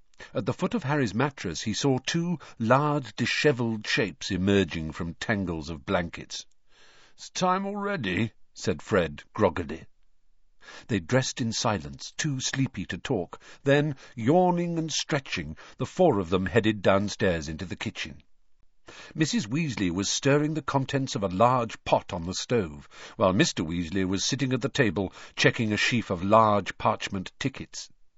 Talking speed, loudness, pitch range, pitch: 155 wpm, -27 LUFS, 95-145 Hz, 115 Hz